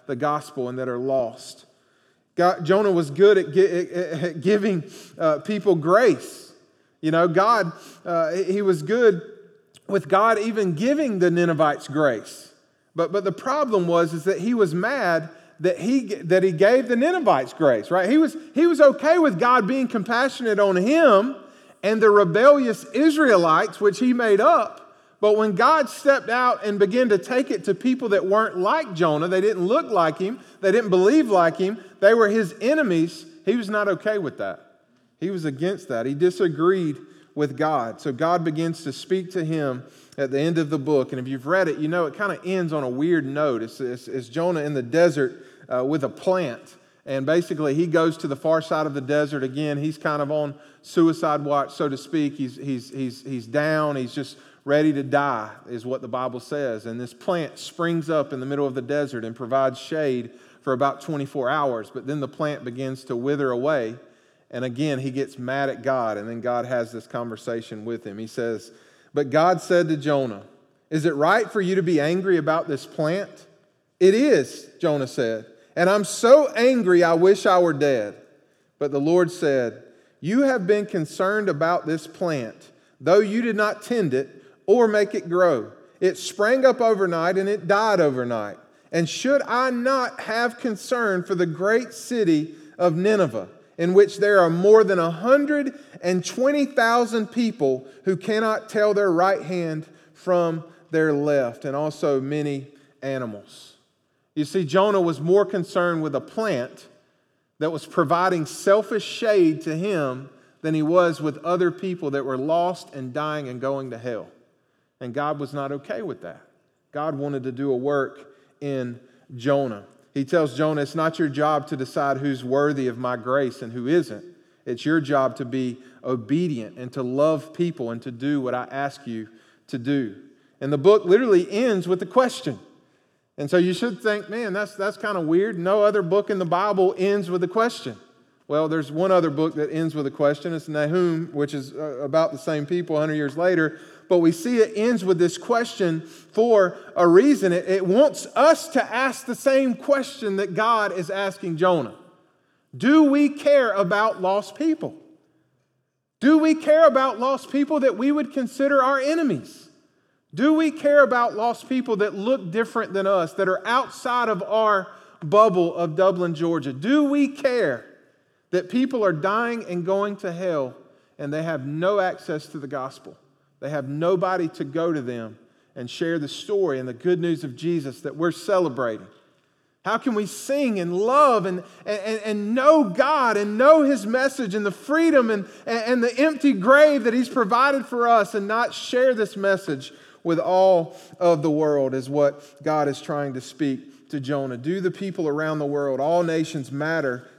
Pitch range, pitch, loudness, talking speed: 145-210 Hz, 175 Hz, -22 LUFS, 185 wpm